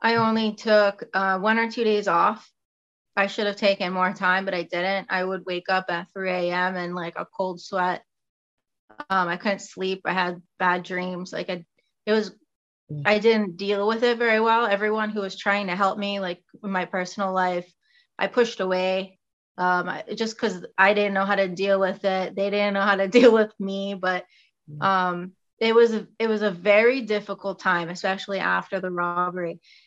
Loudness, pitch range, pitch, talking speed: -23 LUFS, 185-210 Hz, 195 Hz, 195 wpm